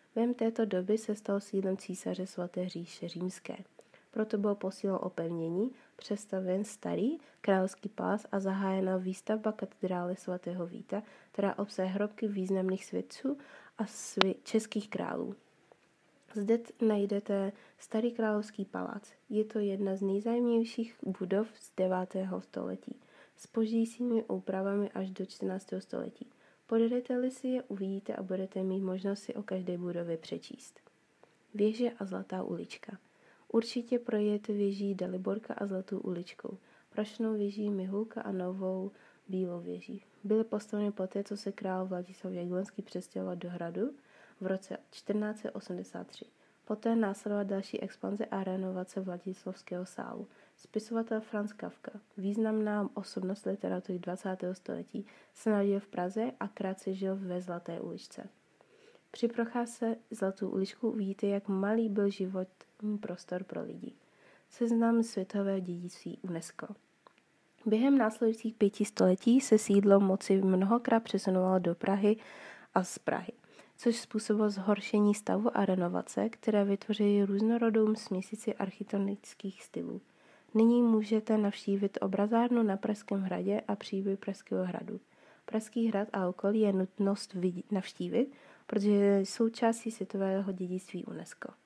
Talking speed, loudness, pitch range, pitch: 125 wpm, -34 LUFS, 190-220 Hz, 200 Hz